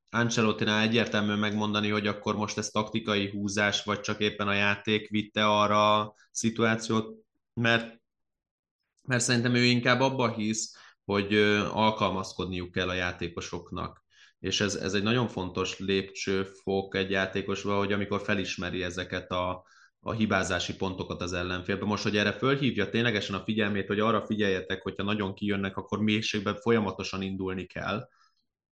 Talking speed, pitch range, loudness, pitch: 140 wpm, 95-110 Hz, -28 LUFS, 105 Hz